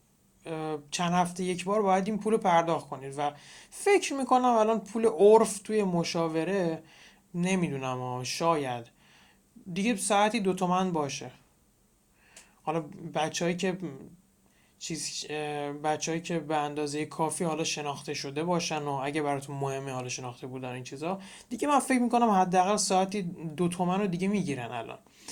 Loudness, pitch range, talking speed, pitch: -29 LUFS, 145-190 Hz, 140 wpm, 165 Hz